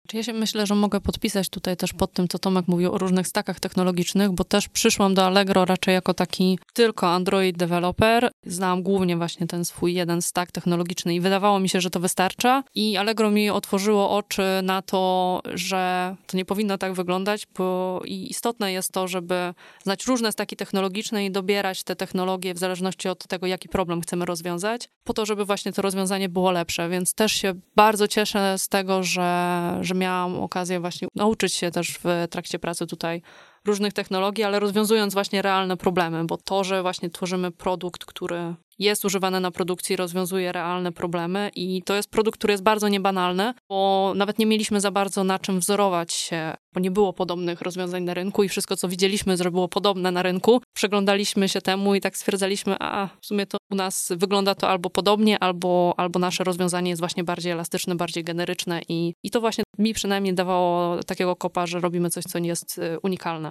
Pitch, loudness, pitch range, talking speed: 190 Hz, -23 LUFS, 180-200 Hz, 190 wpm